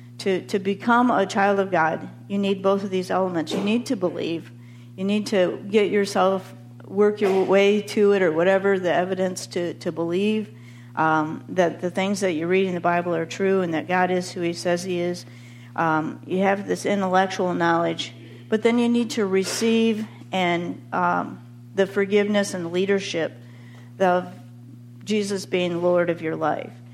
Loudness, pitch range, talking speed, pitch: -23 LUFS, 160-200 Hz, 180 wpm, 180 Hz